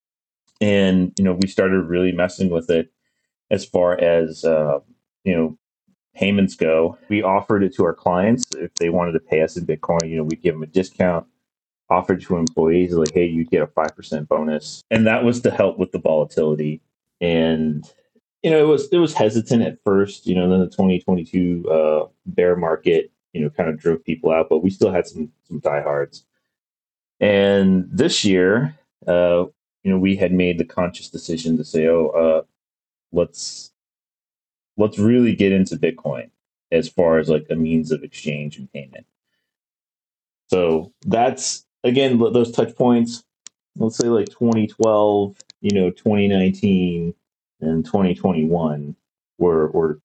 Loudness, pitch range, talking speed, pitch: -19 LUFS, 80-100 Hz, 165 wpm, 90 Hz